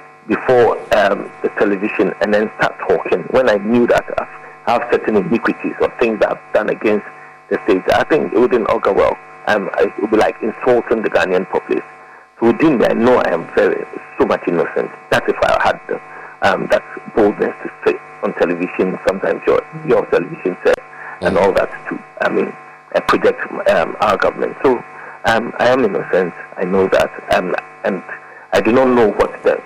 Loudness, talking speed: -16 LUFS, 190 wpm